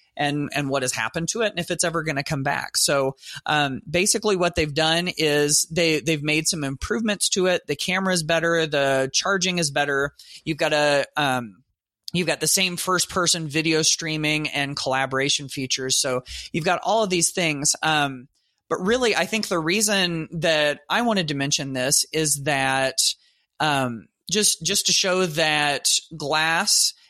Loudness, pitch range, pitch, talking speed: -21 LUFS, 140-180 Hz, 155 Hz, 175 wpm